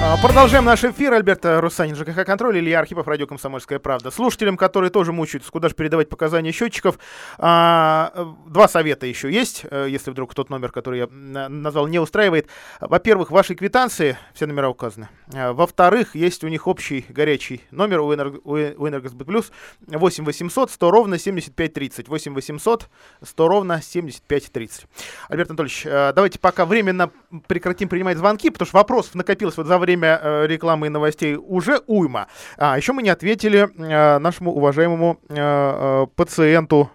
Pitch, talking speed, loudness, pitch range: 165 Hz, 150 wpm, -18 LUFS, 145-190 Hz